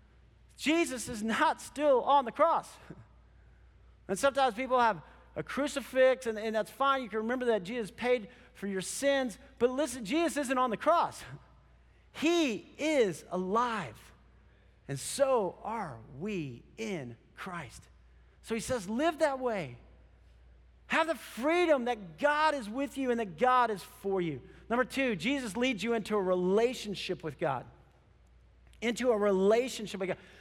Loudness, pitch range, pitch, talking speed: -31 LUFS, 180-260 Hz, 225 Hz, 150 wpm